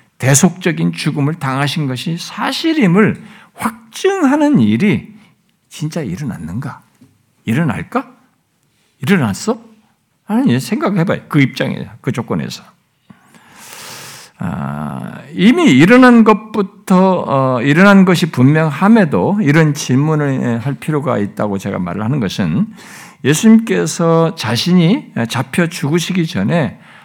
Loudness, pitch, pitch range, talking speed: -14 LUFS, 175 Hz, 145-210 Hz, 245 characters per minute